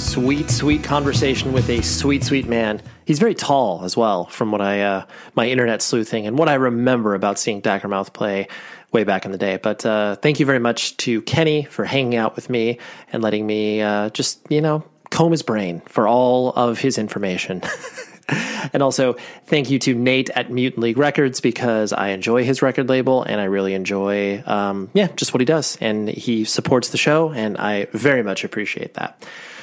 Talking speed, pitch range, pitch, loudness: 200 wpm, 105-135 Hz, 120 Hz, -19 LUFS